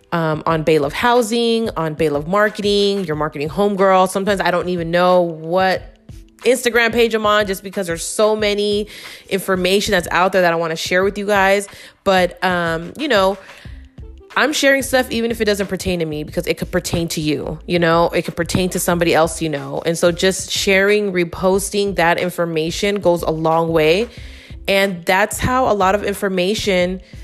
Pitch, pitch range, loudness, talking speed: 185 Hz, 165-205 Hz, -17 LUFS, 190 wpm